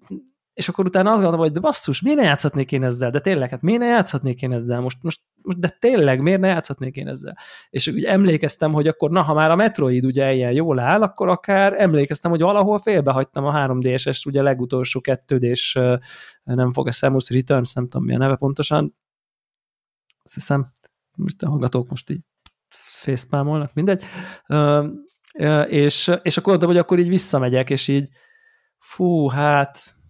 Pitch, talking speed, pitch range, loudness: 150 Hz, 175 wpm, 135-185 Hz, -19 LUFS